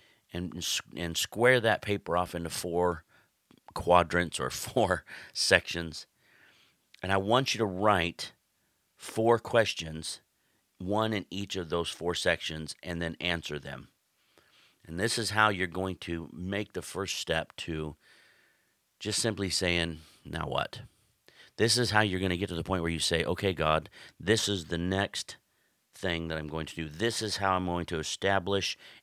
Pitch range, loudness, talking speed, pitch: 85-100 Hz, -30 LUFS, 165 wpm, 90 Hz